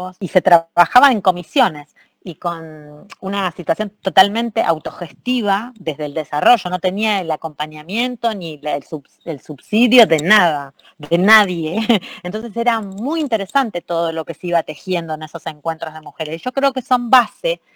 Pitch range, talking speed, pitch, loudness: 160-230 Hz, 160 wpm, 185 Hz, -17 LUFS